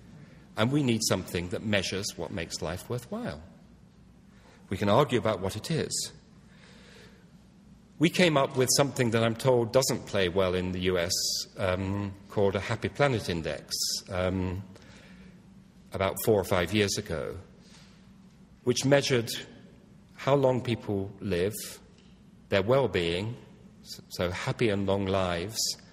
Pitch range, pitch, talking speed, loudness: 95-150 Hz, 115 Hz, 135 wpm, -28 LUFS